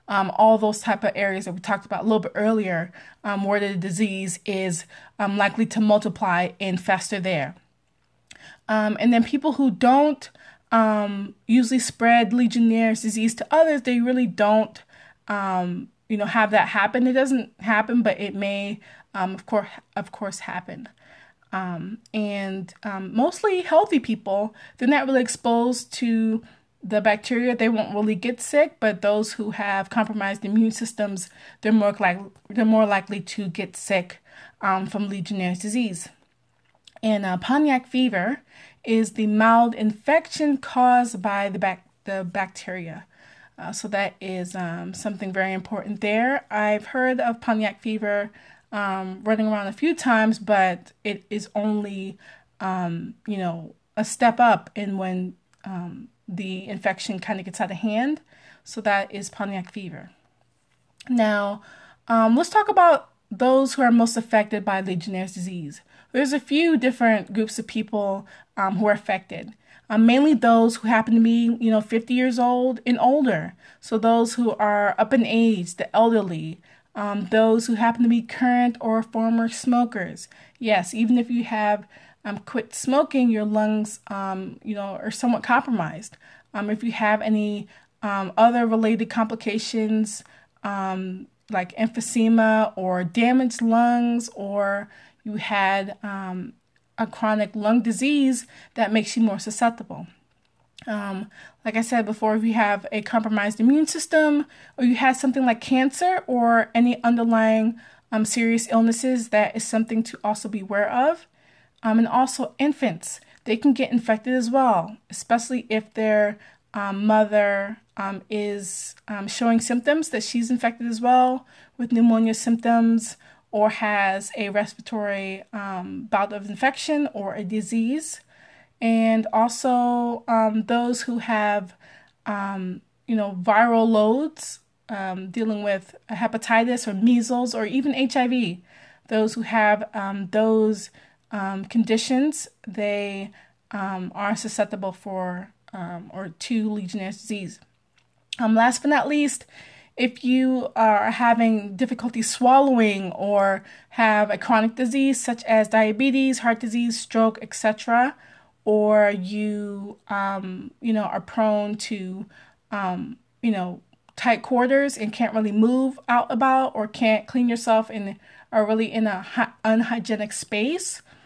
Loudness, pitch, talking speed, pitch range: -22 LUFS, 220 Hz, 145 wpm, 200-235 Hz